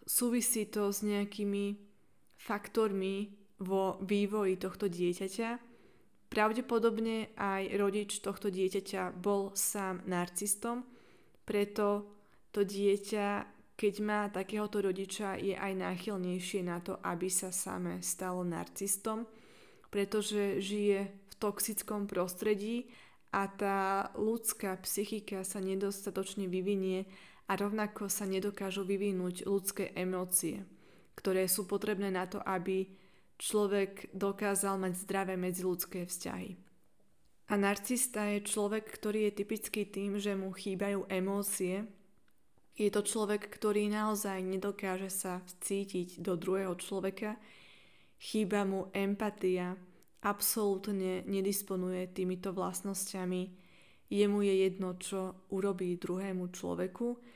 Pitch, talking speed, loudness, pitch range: 200 Hz, 105 wpm, -35 LUFS, 190-210 Hz